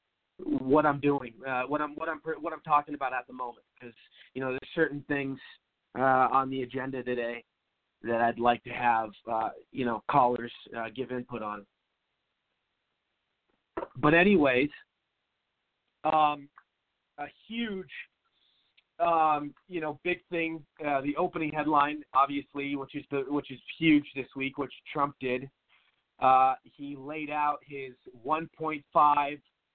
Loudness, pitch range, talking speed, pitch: -29 LUFS, 125-150 Hz, 145 wpm, 140 Hz